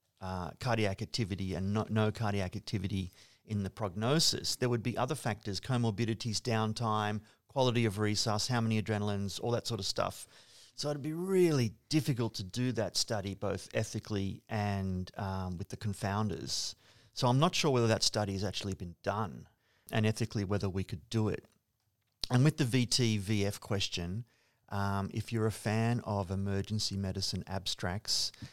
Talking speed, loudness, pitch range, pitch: 165 wpm, -33 LUFS, 100-115 Hz, 110 Hz